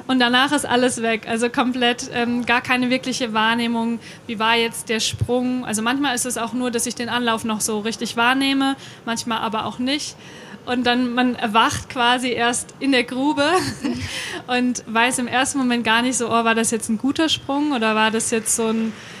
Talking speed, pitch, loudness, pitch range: 205 wpm, 240 Hz, -20 LUFS, 230-250 Hz